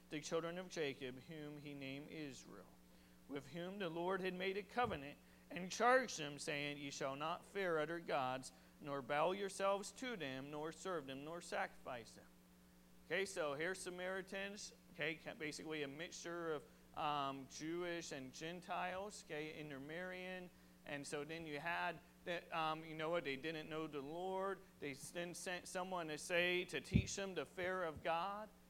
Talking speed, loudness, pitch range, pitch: 165 wpm, -45 LUFS, 145-180 Hz, 160 Hz